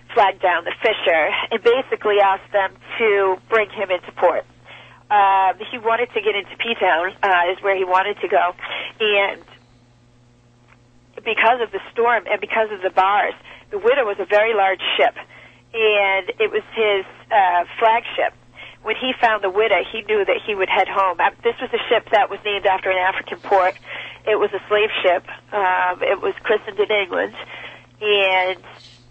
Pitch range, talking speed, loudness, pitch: 185-225 Hz, 175 wpm, -19 LUFS, 205 Hz